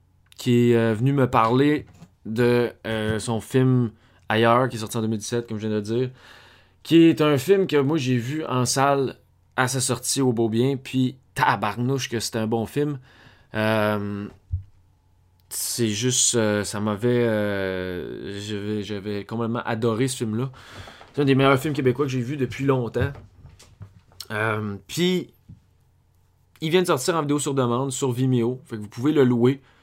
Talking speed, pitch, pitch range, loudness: 175 wpm, 115 Hz, 105-130 Hz, -23 LUFS